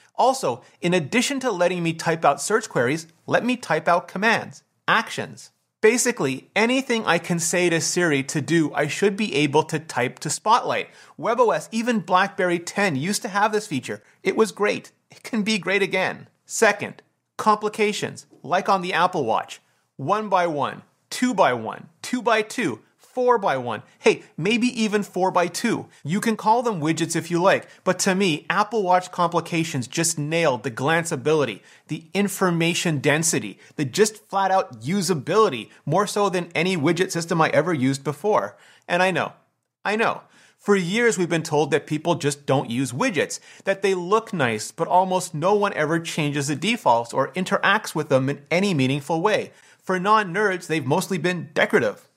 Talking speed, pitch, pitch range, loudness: 175 wpm, 180 Hz, 155-205 Hz, -22 LUFS